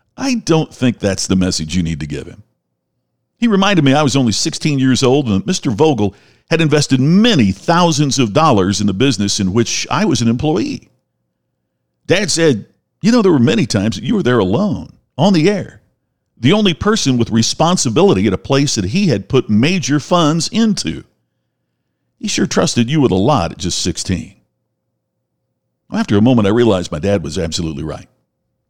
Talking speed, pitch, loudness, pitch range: 190 wpm, 130 Hz, -14 LUFS, 100-160 Hz